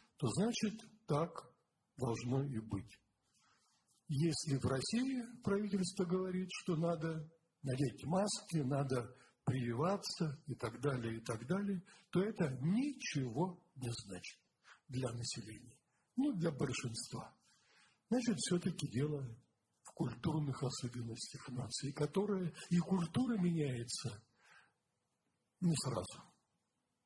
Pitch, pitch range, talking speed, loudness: 150 Hz, 125-185 Hz, 100 wpm, -40 LUFS